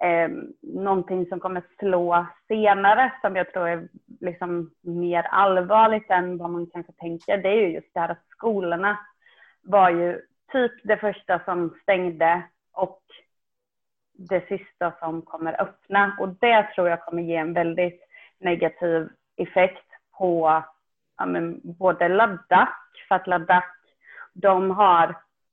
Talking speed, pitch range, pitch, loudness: 135 wpm, 170-200 Hz, 180 Hz, -23 LUFS